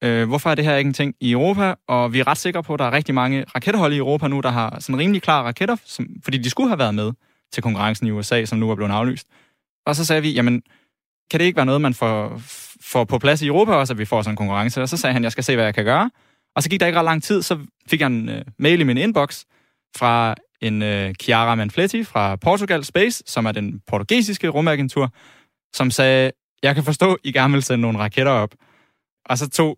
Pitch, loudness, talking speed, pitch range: 135 Hz, -19 LUFS, 255 wpm, 115-155 Hz